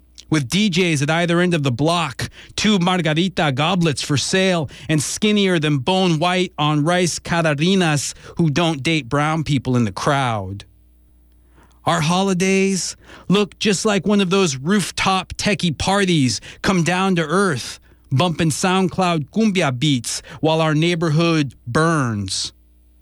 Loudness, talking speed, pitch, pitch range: -18 LUFS, 135 wpm, 165 Hz, 140-185 Hz